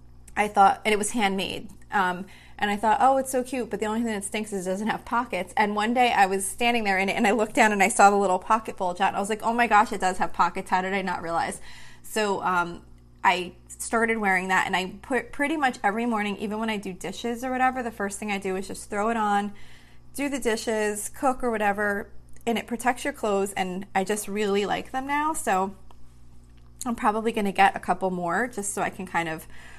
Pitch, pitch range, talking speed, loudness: 205 Hz, 190-230 Hz, 250 wpm, -25 LUFS